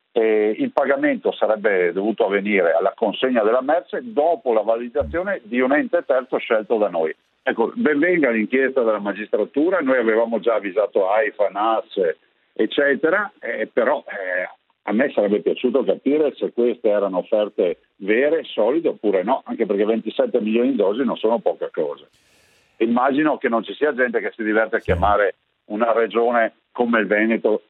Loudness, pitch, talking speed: -20 LUFS, 120 Hz, 160 wpm